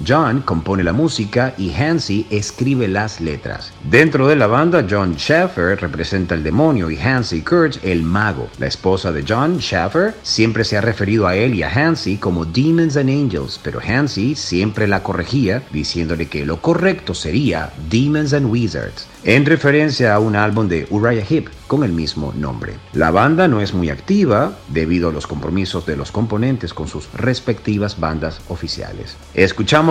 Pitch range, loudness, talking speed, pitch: 85-130 Hz, -17 LUFS, 170 wpm, 105 Hz